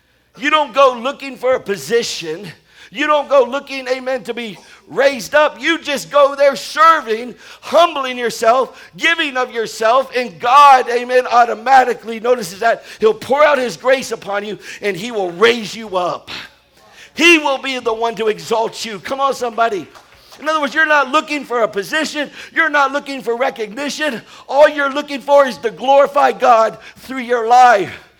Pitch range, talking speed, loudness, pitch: 230-285 Hz, 170 wpm, -15 LUFS, 260 Hz